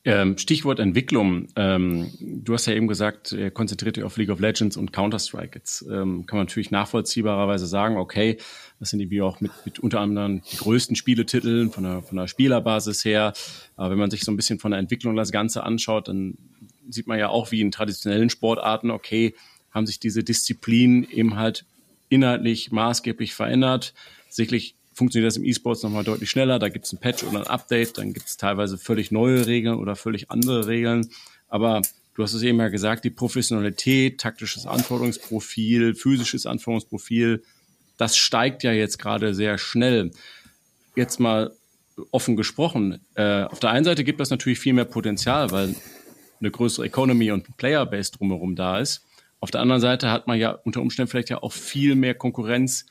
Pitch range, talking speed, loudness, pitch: 105-120 Hz, 185 wpm, -23 LUFS, 115 Hz